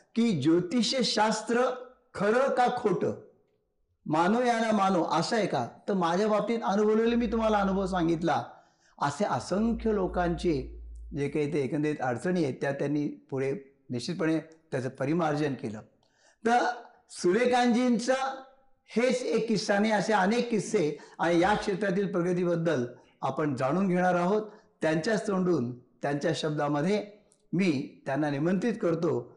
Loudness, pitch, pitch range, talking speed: -28 LUFS, 185 Hz, 155-220 Hz, 125 wpm